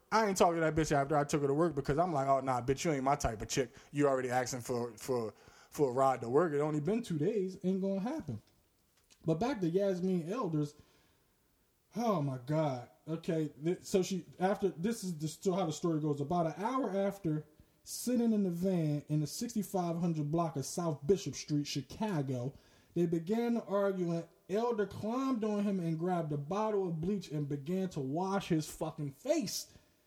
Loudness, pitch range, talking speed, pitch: -34 LUFS, 145-195 Hz, 200 wpm, 165 Hz